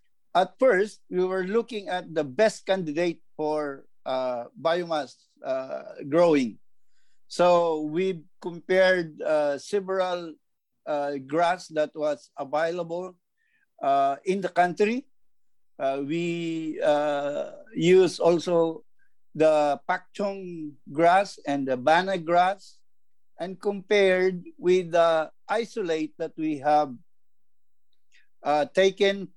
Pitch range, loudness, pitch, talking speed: 155-190 Hz, -25 LUFS, 175 Hz, 100 wpm